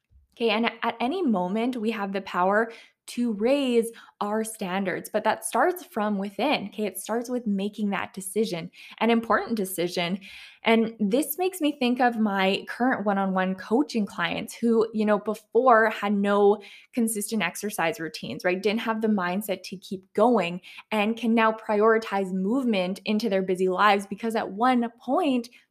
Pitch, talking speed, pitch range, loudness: 215 Hz, 165 wpm, 195-230 Hz, -25 LUFS